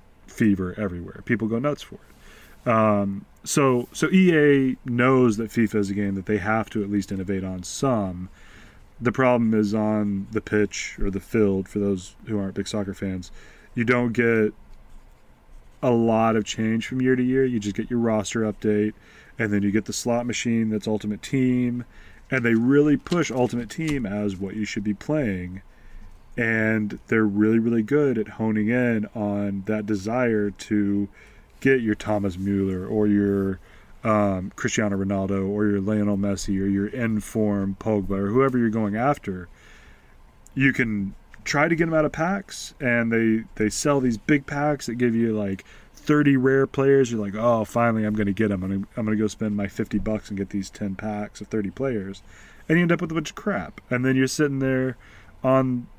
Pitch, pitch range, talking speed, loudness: 110 Hz, 100-125 Hz, 190 wpm, -23 LUFS